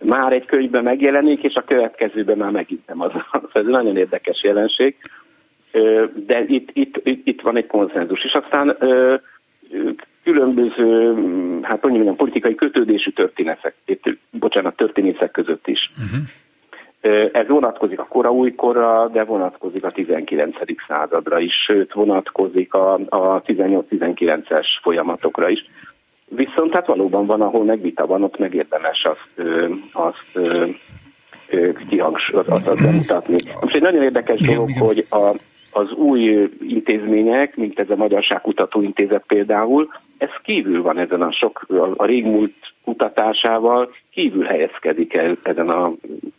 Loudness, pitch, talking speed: -18 LUFS, 130 Hz, 125 wpm